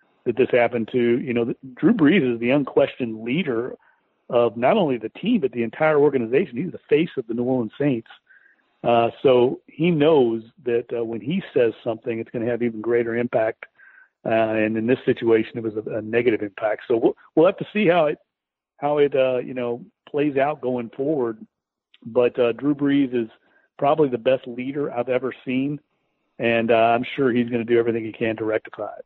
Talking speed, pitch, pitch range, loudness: 205 wpm, 120 Hz, 115-135 Hz, -22 LUFS